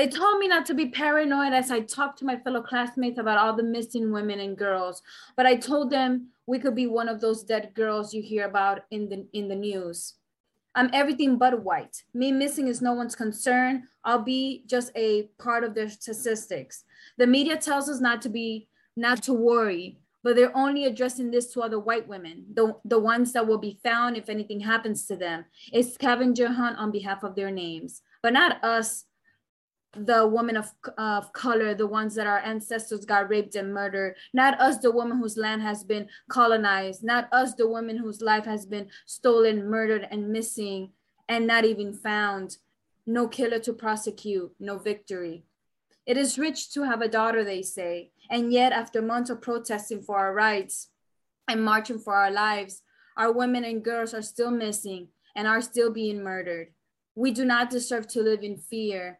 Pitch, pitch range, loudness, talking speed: 225 Hz, 210-245 Hz, -26 LUFS, 190 wpm